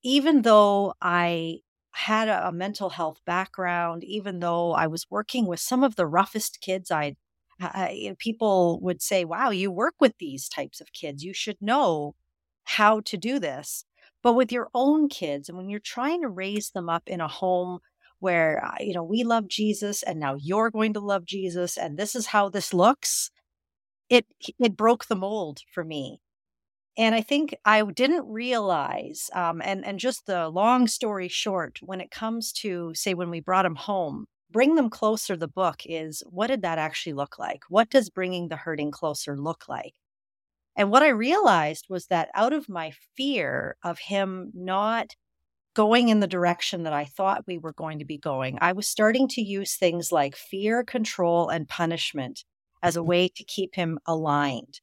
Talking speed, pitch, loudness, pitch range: 185 wpm, 190 Hz, -25 LUFS, 170-220 Hz